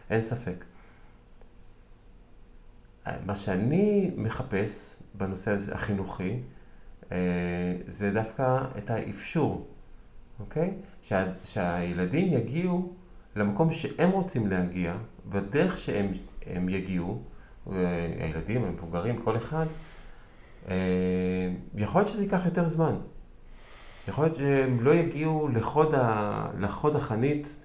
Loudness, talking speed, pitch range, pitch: -29 LUFS, 85 wpm, 90-150 Hz, 105 Hz